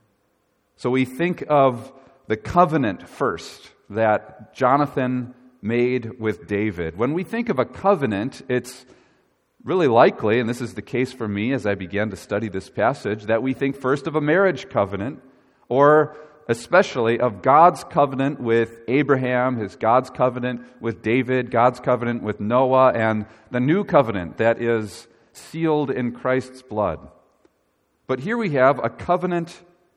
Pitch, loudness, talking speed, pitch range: 125 Hz, -21 LUFS, 150 wpm, 115-140 Hz